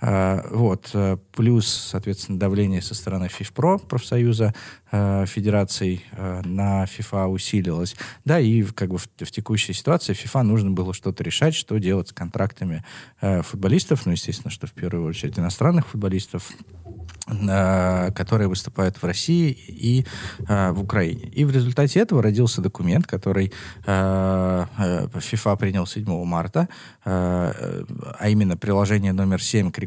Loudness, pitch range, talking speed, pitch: -22 LUFS, 95-115 Hz, 125 wpm, 100 Hz